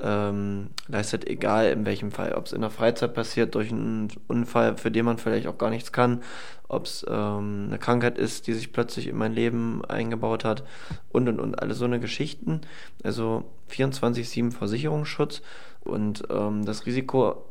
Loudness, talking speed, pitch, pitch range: -27 LUFS, 170 wpm, 115 Hz, 110-120 Hz